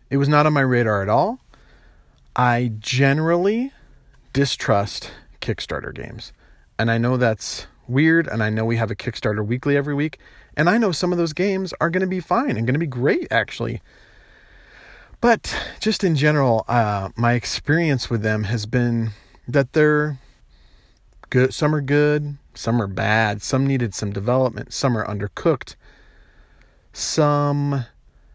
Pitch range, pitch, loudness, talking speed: 115-150 Hz, 130 Hz, -21 LUFS, 155 wpm